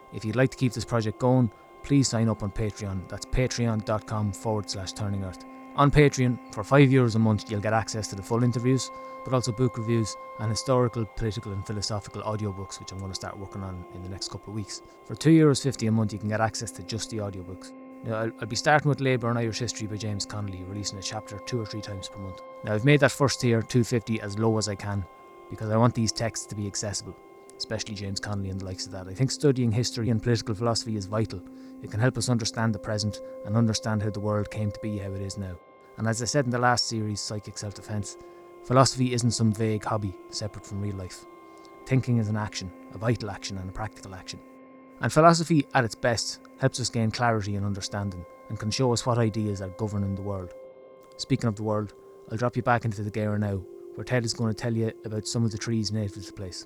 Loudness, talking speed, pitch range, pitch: -27 LUFS, 240 wpm, 105-125 Hz, 110 Hz